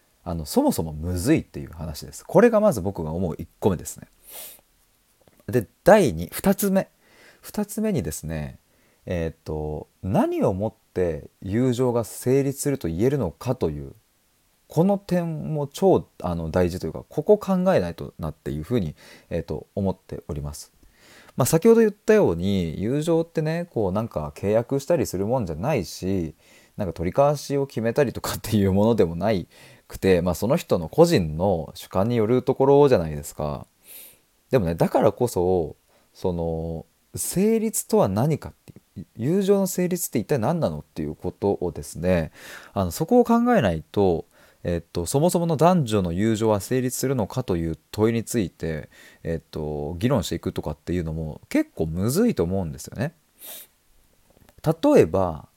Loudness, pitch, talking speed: -23 LUFS, 110 Hz, 300 characters per minute